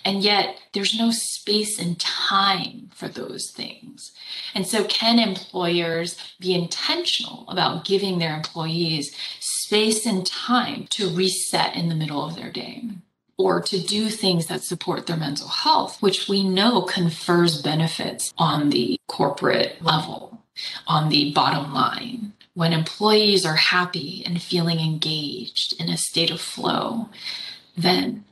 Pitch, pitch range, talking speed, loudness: 185 Hz, 170-210 Hz, 140 wpm, -22 LUFS